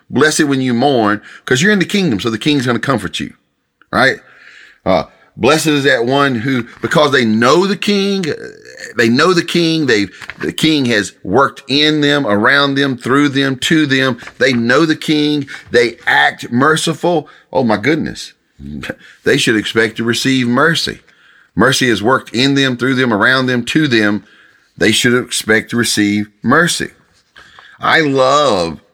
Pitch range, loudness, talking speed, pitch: 115-155 Hz, -13 LUFS, 165 wpm, 130 Hz